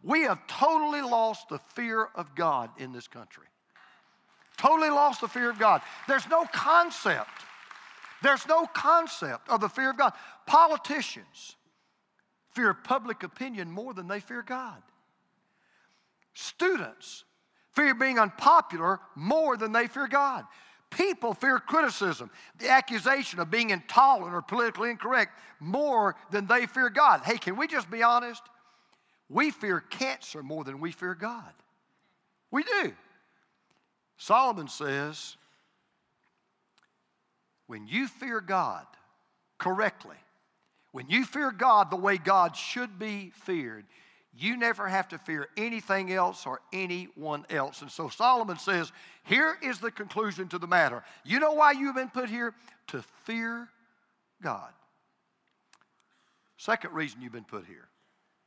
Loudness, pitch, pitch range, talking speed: -27 LUFS, 230 Hz, 185-265 Hz, 135 wpm